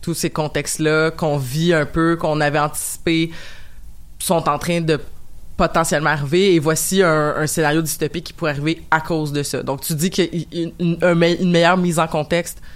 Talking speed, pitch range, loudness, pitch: 200 wpm, 150-170 Hz, -18 LUFS, 160 Hz